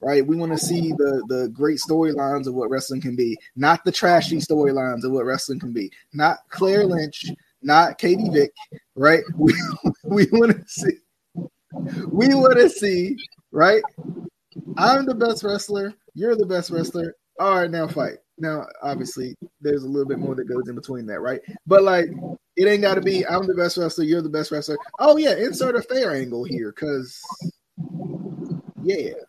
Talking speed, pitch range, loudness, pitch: 180 wpm, 145-200 Hz, -20 LUFS, 170 Hz